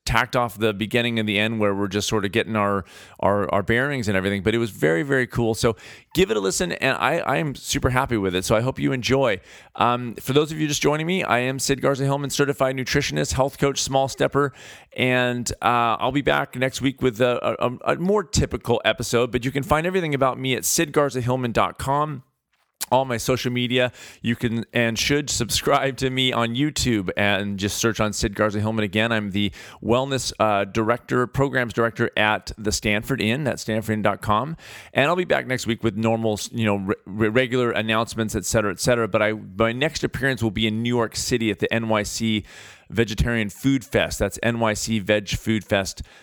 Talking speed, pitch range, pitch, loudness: 205 wpm, 110-130 Hz, 115 Hz, -22 LUFS